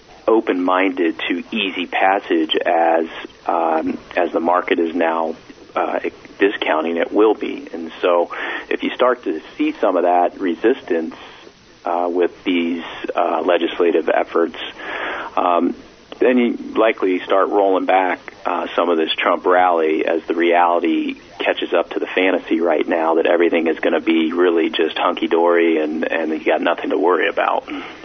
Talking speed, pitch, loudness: 155 wpm, 95 Hz, -18 LUFS